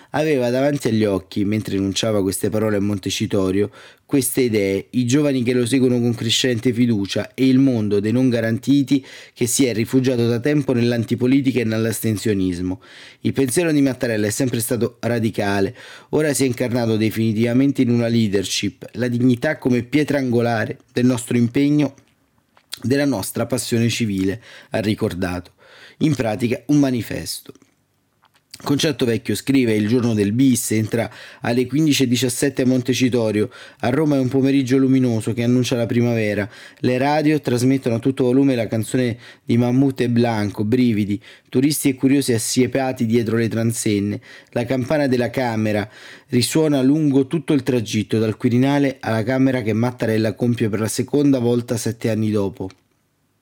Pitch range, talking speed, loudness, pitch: 110-135 Hz, 150 wpm, -19 LUFS, 120 Hz